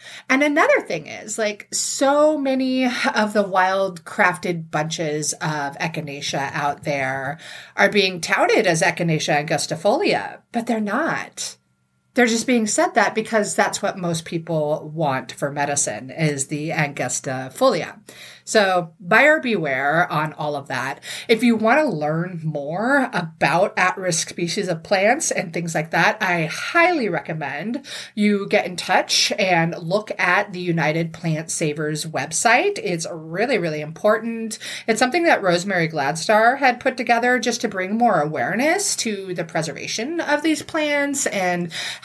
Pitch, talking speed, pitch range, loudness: 180 Hz, 145 wpm, 155-230 Hz, -20 LUFS